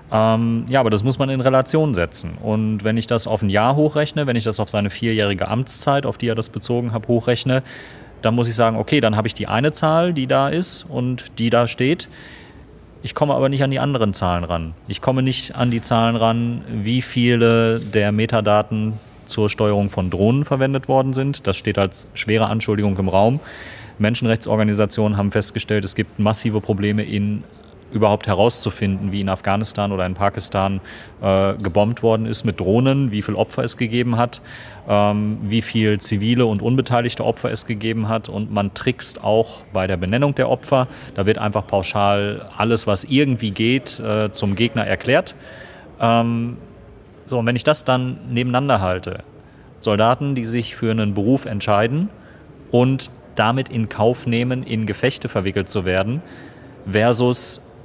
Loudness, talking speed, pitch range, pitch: -19 LUFS, 175 wpm, 105-125 Hz, 115 Hz